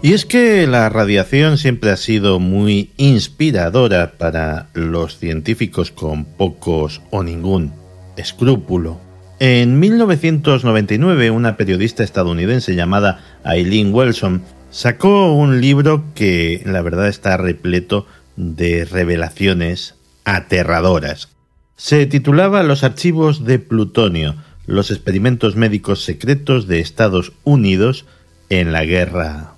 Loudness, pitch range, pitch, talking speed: -15 LUFS, 85-125 Hz, 95 Hz, 110 wpm